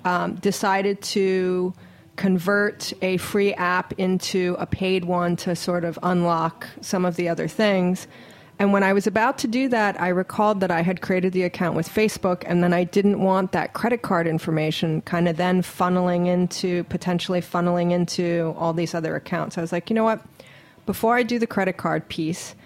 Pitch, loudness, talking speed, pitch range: 180 Hz, -22 LUFS, 190 wpm, 175-200 Hz